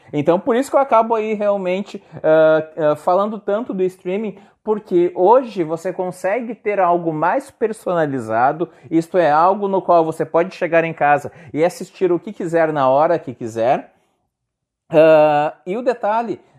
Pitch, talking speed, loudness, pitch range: 175 Hz, 165 wpm, -17 LUFS, 160-205 Hz